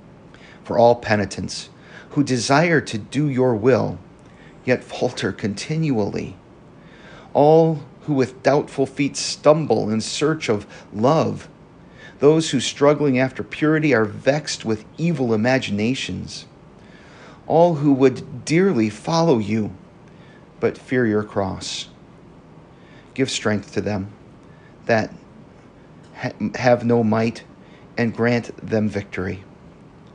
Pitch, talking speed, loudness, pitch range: 130 Hz, 110 wpm, -20 LUFS, 110-145 Hz